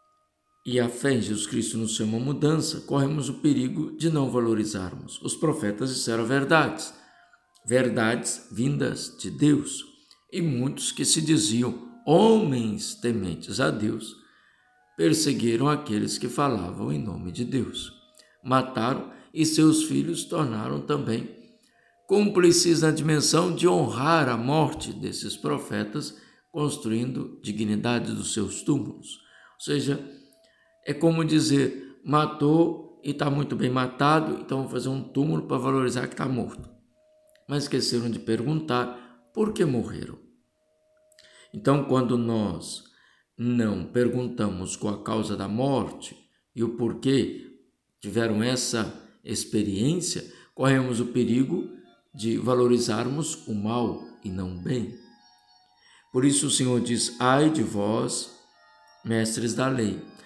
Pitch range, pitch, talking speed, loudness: 115-150 Hz, 125 Hz, 125 wpm, -25 LUFS